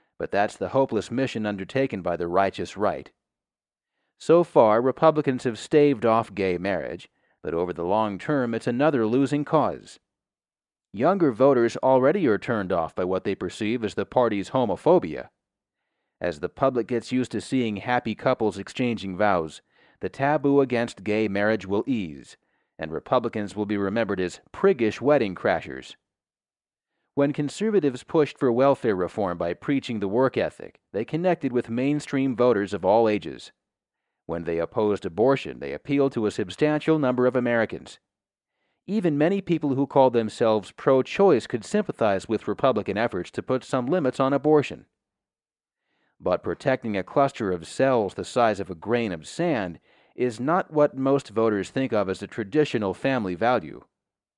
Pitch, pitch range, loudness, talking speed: 120 Hz, 105-140 Hz, -24 LUFS, 155 wpm